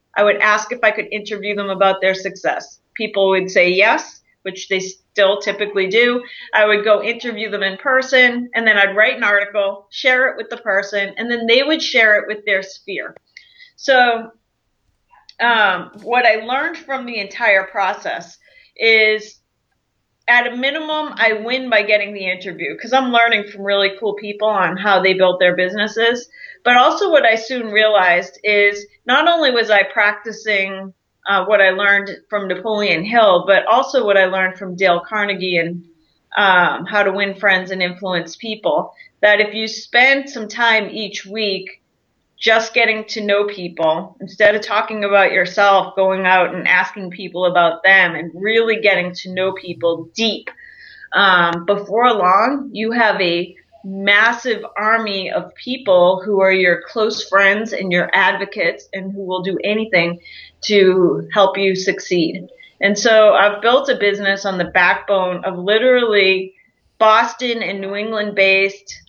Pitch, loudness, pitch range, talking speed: 205 Hz, -15 LUFS, 190-225 Hz, 165 wpm